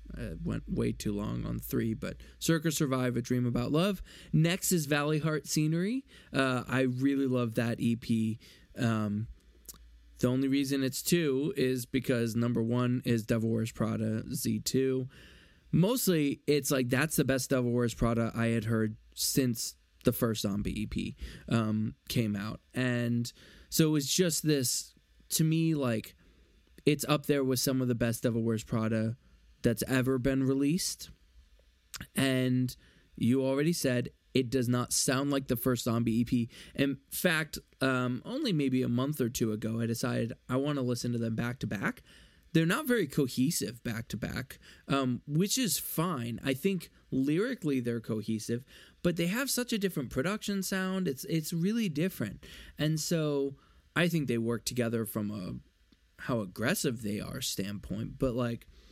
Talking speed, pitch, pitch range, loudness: 165 wpm, 125 Hz, 115-145 Hz, -31 LUFS